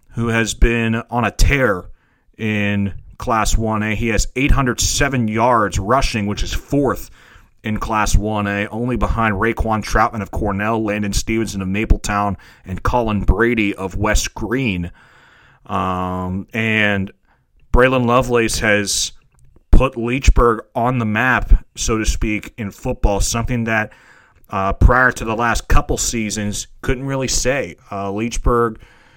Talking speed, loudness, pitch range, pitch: 140 wpm, -18 LUFS, 100-115 Hz, 110 Hz